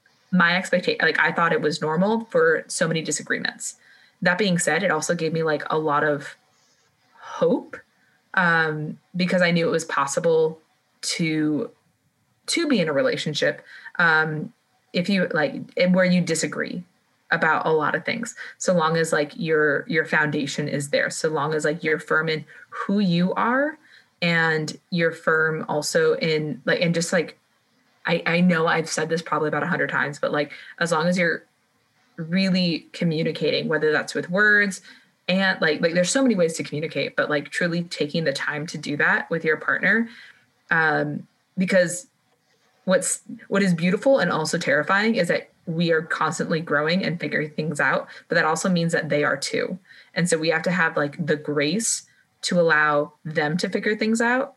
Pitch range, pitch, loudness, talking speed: 155-190 Hz, 170 Hz, -22 LUFS, 180 wpm